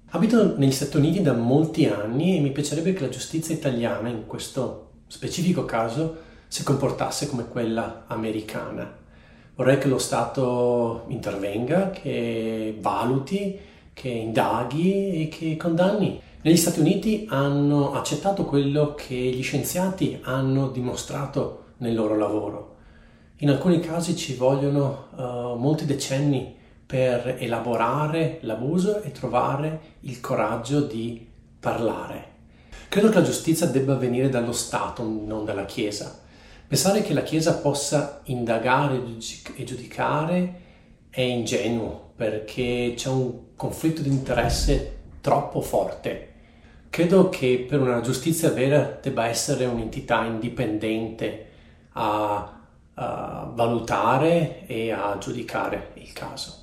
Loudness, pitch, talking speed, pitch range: -24 LUFS, 130 Hz, 120 wpm, 115-150 Hz